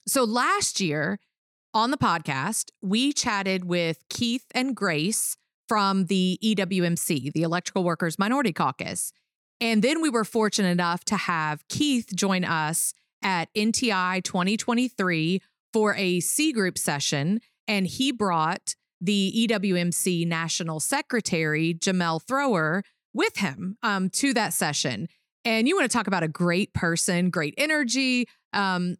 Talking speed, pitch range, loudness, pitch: 135 wpm, 175-230 Hz, -25 LUFS, 195 Hz